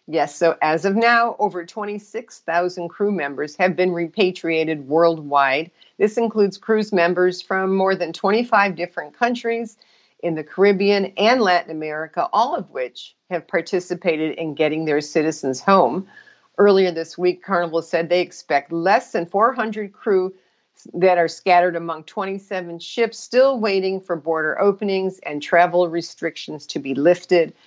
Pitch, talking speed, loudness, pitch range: 180 Hz, 145 wpm, -20 LUFS, 165-200 Hz